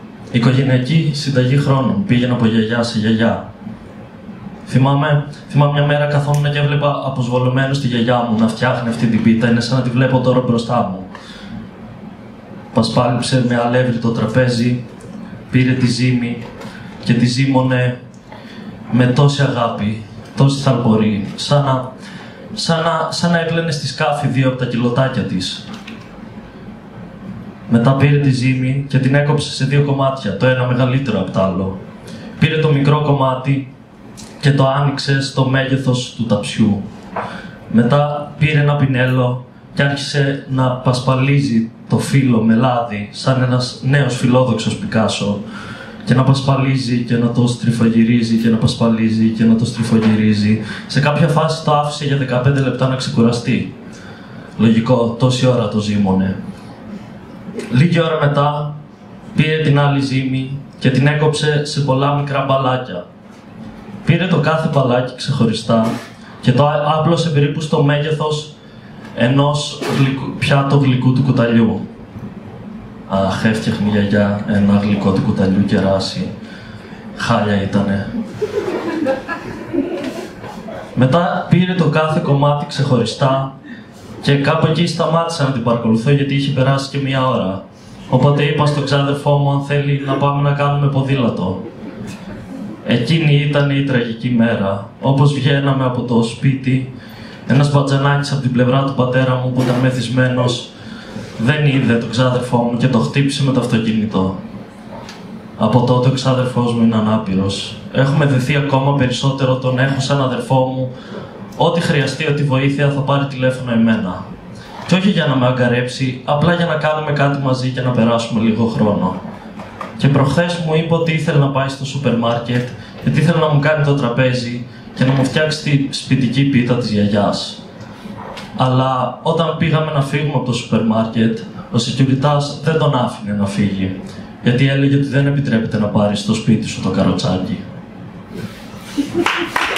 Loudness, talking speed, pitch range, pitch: -15 LUFS, 145 wpm, 120-145 Hz, 130 Hz